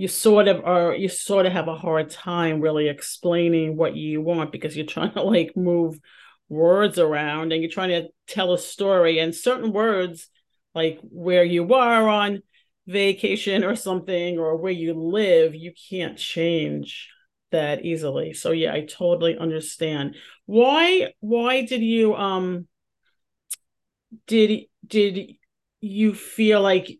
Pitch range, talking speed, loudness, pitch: 165-205 Hz, 145 wpm, -22 LUFS, 180 Hz